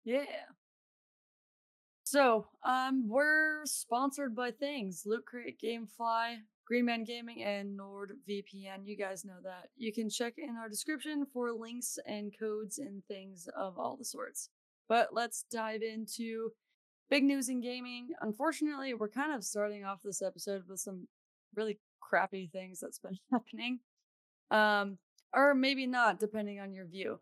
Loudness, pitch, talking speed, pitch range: -35 LUFS, 225 Hz, 150 wpm, 205-260 Hz